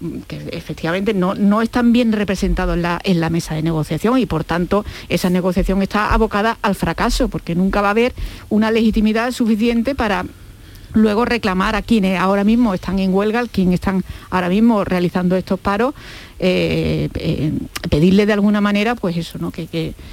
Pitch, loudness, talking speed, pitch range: 195 Hz, -17 LUFS, 175 wpm, 175-220 Hz